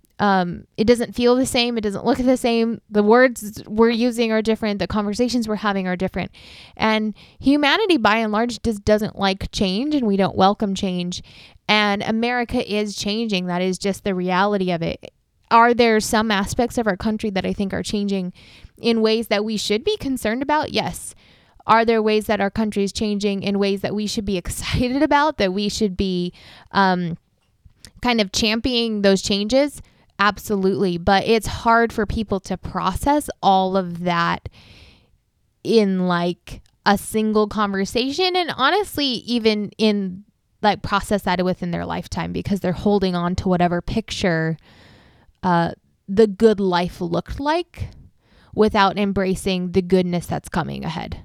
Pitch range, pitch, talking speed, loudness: 190-225 Hz, 205 Hz, 165 wpm, -20 LUFS